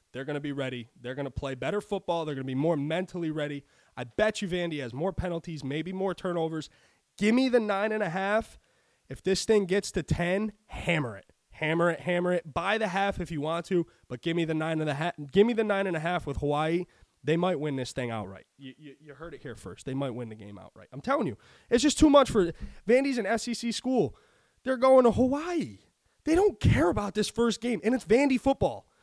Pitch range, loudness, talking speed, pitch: 145-215 Hz, -28 LUFS, 240 wpm, 175 Hz